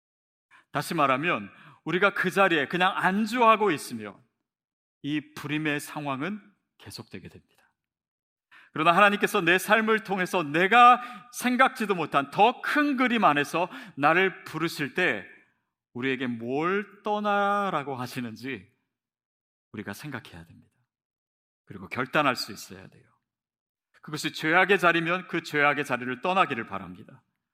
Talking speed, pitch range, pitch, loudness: 280 characters per minute, 140-205 Hz, 170 Hz, -25 LUFS